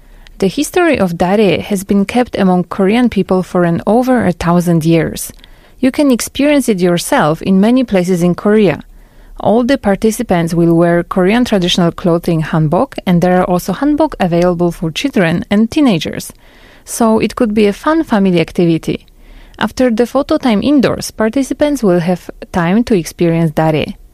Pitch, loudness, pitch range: 195 Hz, -12 LUFS, 175-245 Hz